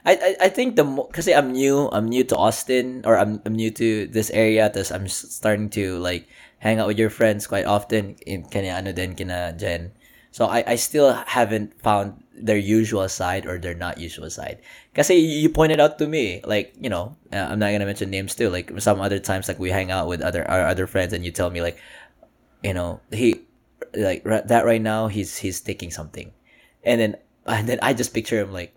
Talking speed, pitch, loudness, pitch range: 210 wpm, 105 Hz, -22 LUFS, 95-115 Hz